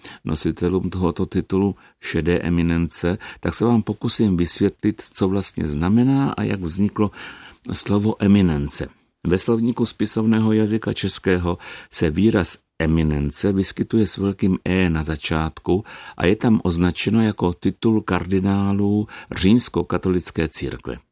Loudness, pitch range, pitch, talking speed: -20 LUFS, 85-105 Hz, 95 Hz, 115 wpm